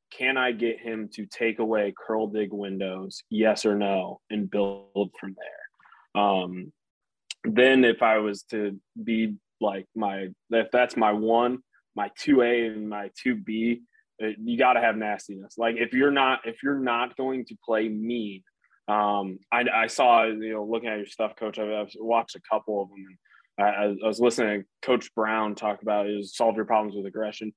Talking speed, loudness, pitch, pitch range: 185 wpm, -26 LUFS, 110 Hz, 105-115 Hz